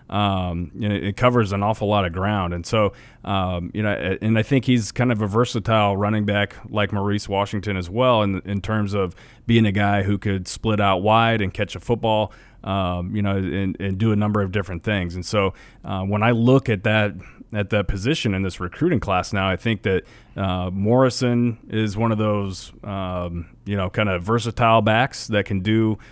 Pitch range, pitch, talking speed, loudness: 95-110 Hz, 105 Hz, 210 wpm, -21 LUFS